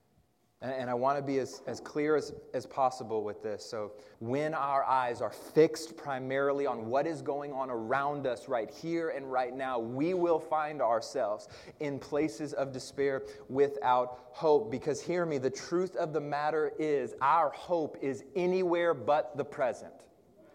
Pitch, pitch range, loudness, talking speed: 140 Hz, 130-155 Hz, -32 LUFS, 170 wpm